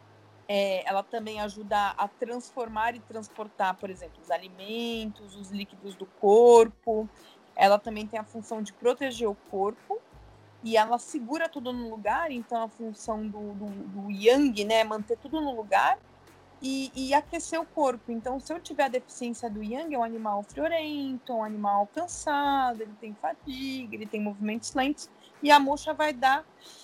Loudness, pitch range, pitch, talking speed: -28 LUFS, 210-270 Hz, 230 Hz, 170 wpm